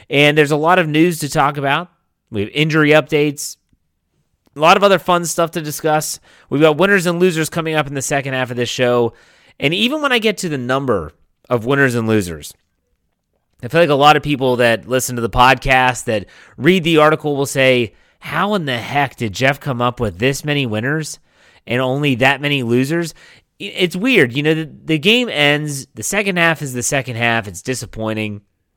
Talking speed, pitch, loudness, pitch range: 205 wpm, 140 Hz, -15 LUFS, 125-160 Hz